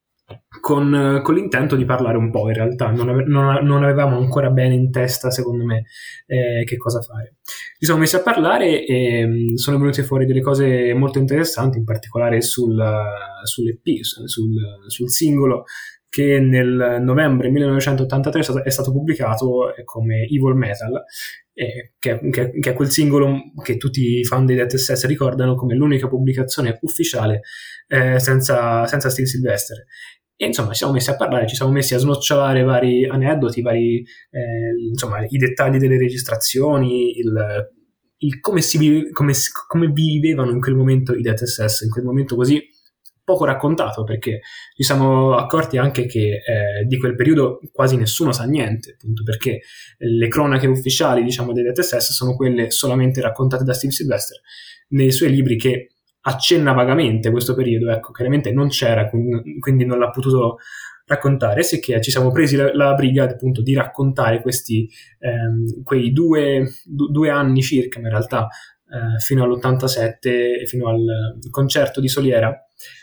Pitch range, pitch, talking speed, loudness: 120-140 Hz, 130 Hz, 155 wpm, -18 LUFS